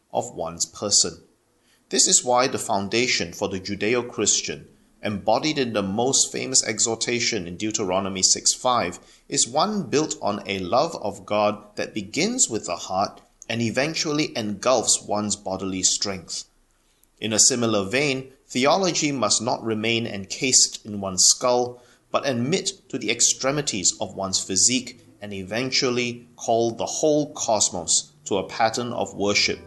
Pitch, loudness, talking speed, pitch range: 115 Hz, -22 LUFS, 145 wpm, 100-125 Hz